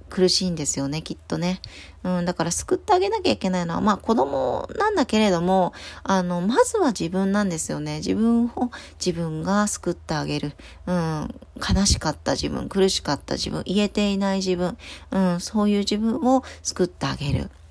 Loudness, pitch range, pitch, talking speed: -23 LUFS, 175-215 Hz, 190 Hz, 365 characters per minute